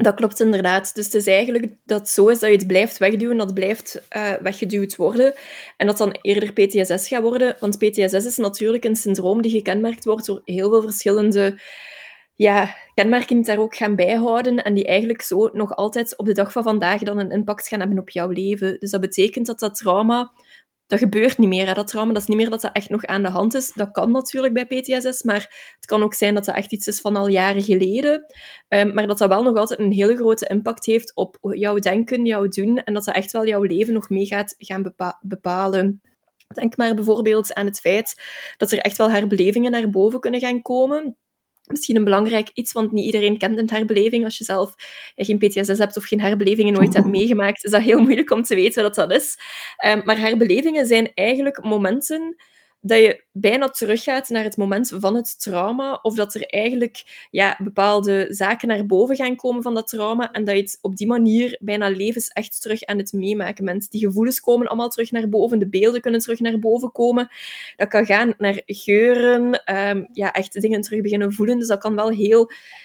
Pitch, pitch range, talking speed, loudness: 215 Hz, 200-230 Hz, 215 wpm, -19 LUFS